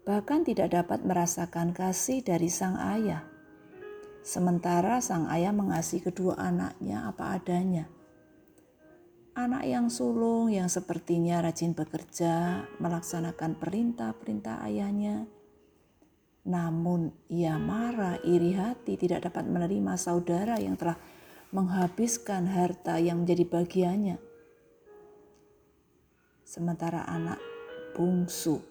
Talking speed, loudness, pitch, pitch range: 95 wpm, -30 LUFS, 175 Hz, 170-215 Hz